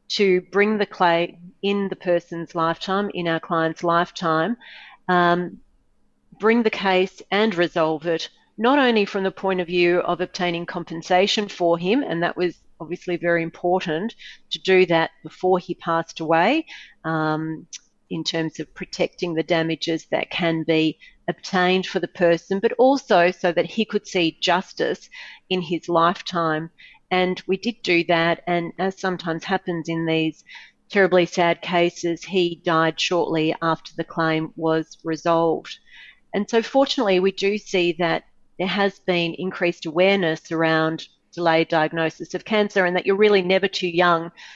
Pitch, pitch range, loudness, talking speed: 175 Hz, 165-190 Hz, -21 LUFS, 155 wpm